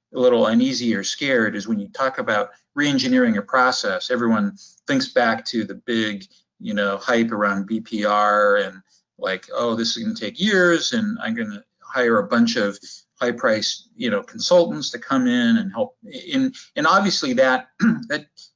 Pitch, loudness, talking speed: 185 Hz, -20 LUFS, 180 wpm